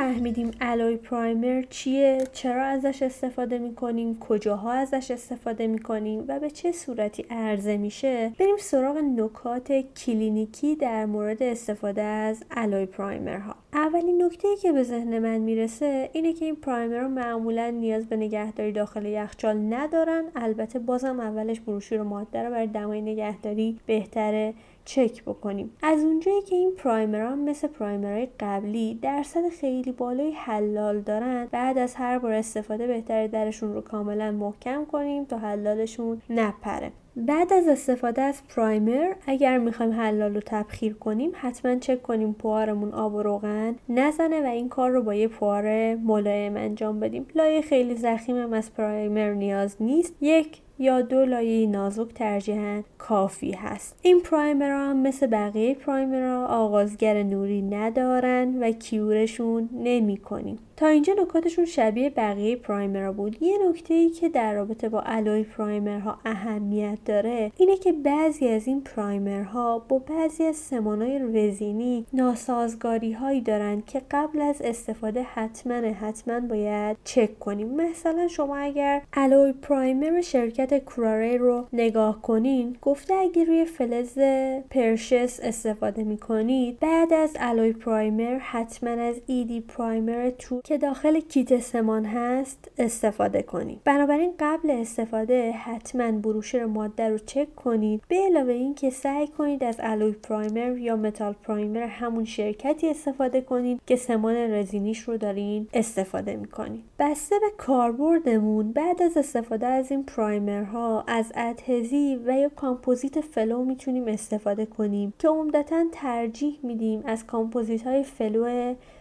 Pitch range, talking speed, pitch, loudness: 215-270 Hz, 145 wpm, 235 Hz, -26 LUFS